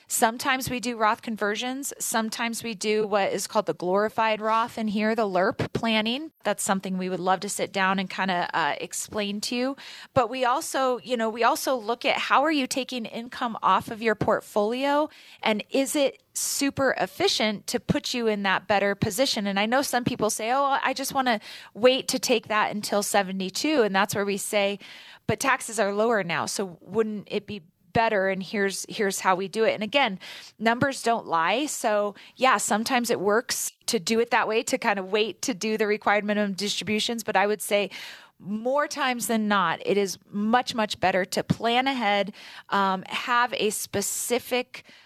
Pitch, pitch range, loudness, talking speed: 220 Hz, 200-245 Hz, -25 LUFS, 200 wpm